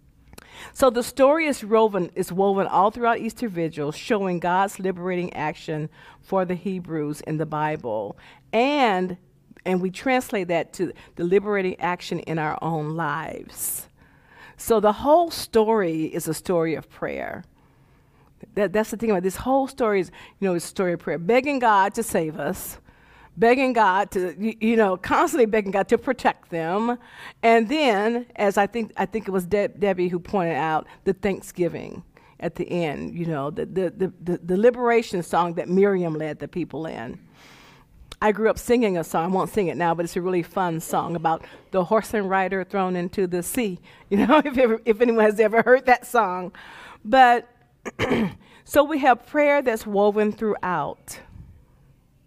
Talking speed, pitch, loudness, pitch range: 175 wpm, 195 Hz, -23 LUFS, 175-225 Hz